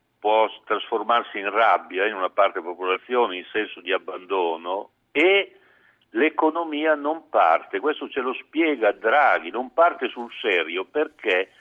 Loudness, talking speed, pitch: -23 LUFS, 135 wpm, 155 Hz